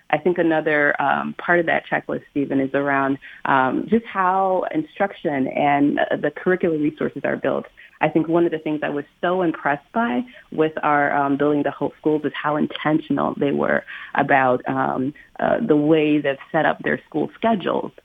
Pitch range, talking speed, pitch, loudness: 140-175 Hz, 185 wpm, 150 Hz, -21 LUFS